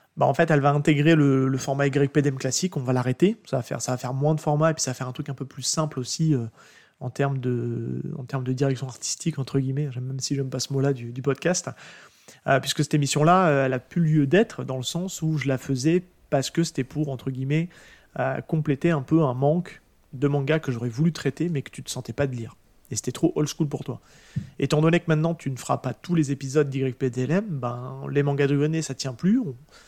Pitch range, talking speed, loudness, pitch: 130-155 Hz, 255 wpm, -25 LUFS, 140 Hz